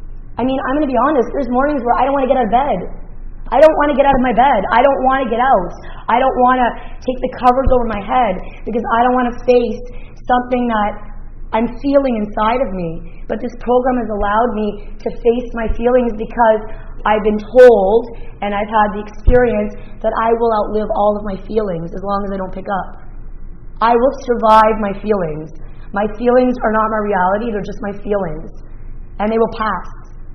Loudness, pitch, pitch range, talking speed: -15 LUFS, 225 Hz, 205-250 Hz, 215 wpm